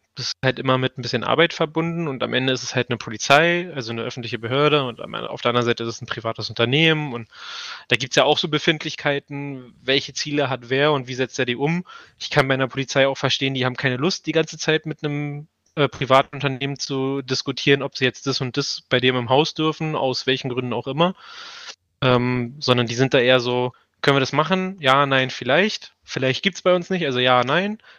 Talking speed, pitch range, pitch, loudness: 230 wpm, 125-150 Hz, 135 Hz, -21 LUFS